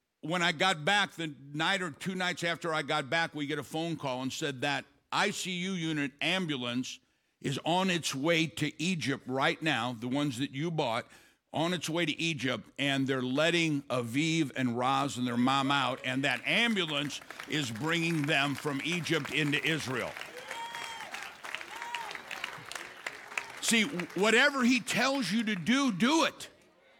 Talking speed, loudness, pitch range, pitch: 160 wpm, -31 LUFS, 140-180 Hz, 160 Hz